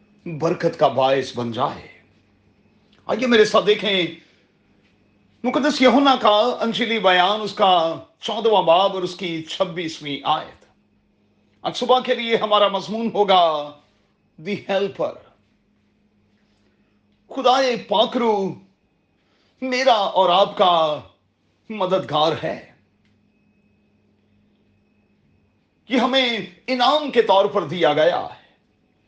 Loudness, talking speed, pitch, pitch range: -19 LUFS, 100 wpm, 195 Hz, 155-225 Hz